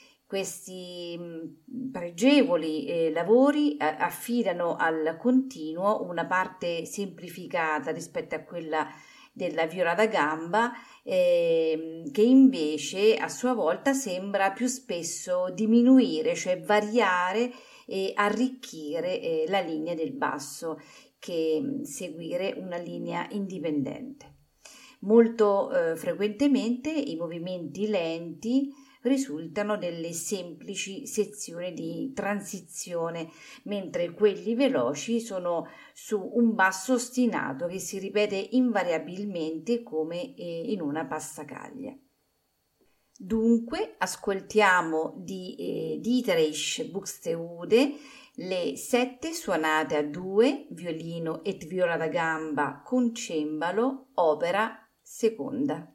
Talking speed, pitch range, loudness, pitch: 95 wpm, 165-245 Hz, -27 LUFS, 195 Hz